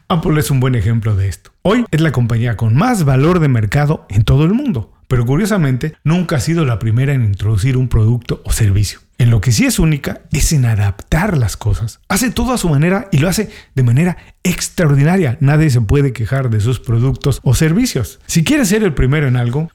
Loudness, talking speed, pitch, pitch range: -14 LUFS, 215 wpm, 135 Hz, 115-165 Hz